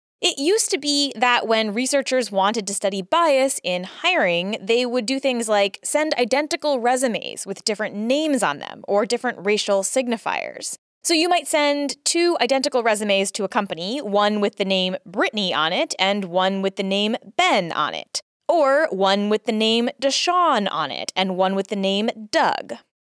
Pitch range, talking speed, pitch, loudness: 200-280 Hz, 180 wpm, 230 Hz, -21 LUFS